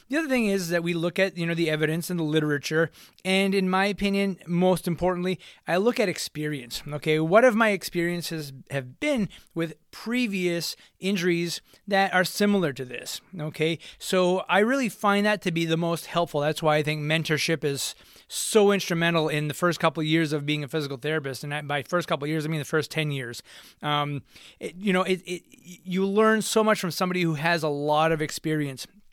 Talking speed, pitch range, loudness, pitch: 205 wpm, 155-190 Hz, -25 LUFS, 170 Hz